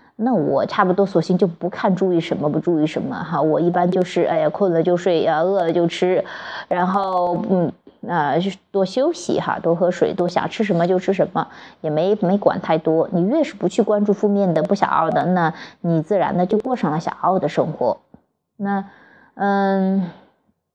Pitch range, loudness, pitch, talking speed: 170-200 Hz, -19 LUFS, 185 Hz, 270 characters per minute